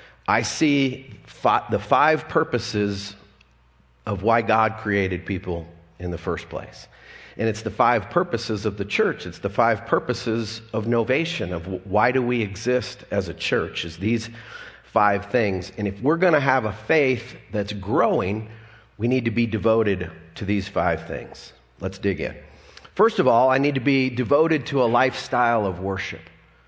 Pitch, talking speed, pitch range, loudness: 110 Hz, 170 wpm, 100-125 Hz, -23 LUFS